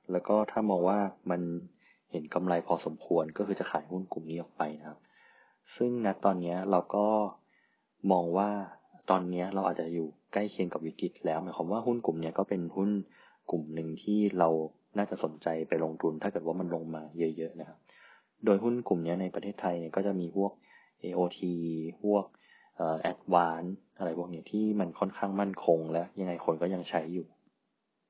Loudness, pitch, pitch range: -32 LUFS, 90 Hz, 85-100 Hz